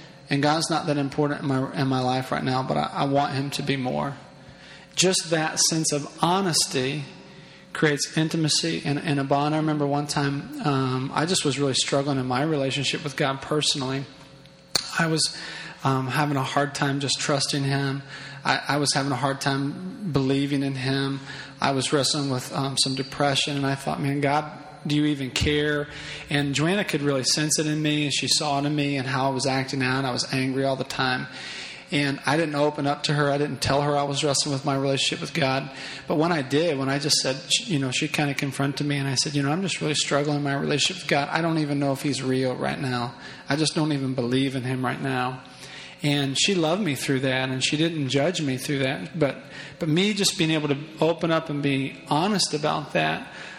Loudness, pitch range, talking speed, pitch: -24 LUFS, 135-150 Hz, 225 wpm, 145 Hz